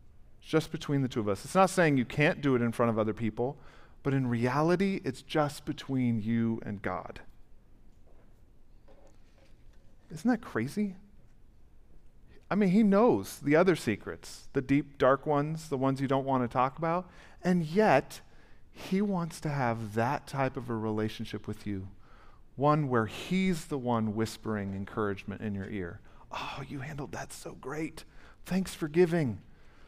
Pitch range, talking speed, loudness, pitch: 110-155 Hz, 165 wpm, -30 LUFS, 130 Hz